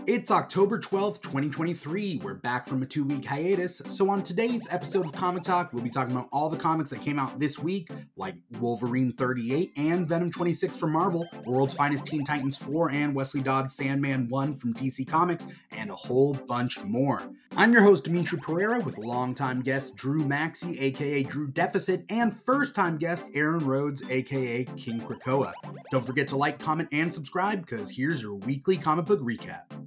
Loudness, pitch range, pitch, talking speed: -28 LUFS, 135-175 Hz, 145 Hz, 180 wpm